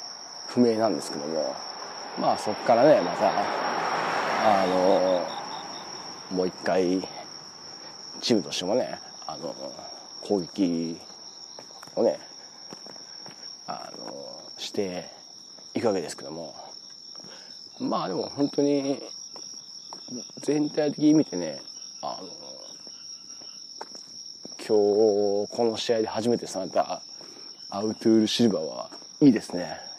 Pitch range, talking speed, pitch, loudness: 100-140 Hz, 190 characters per minute, 110 Hz, -26 LUFS